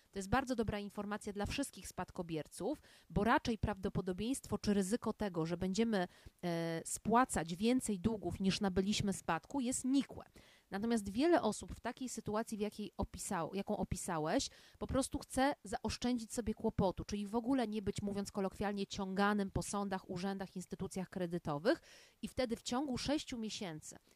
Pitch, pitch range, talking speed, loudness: 205 Hz, 190-235 Hz, 150 wpm, -38 LUFS